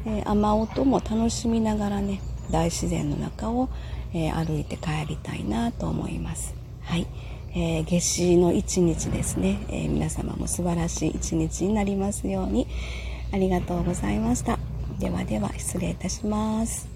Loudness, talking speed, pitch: -26 LUFS, 295 characters per minute, 170 Hz